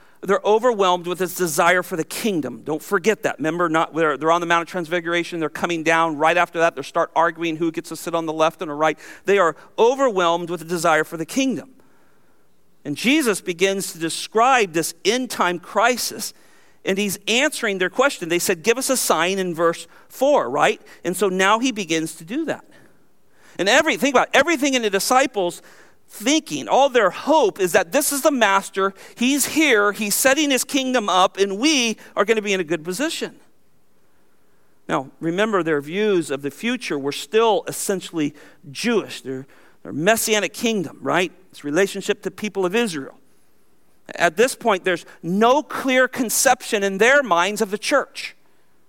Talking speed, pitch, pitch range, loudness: 185 wpm, 195 Hz, 170-235 Hz, -20 LUFS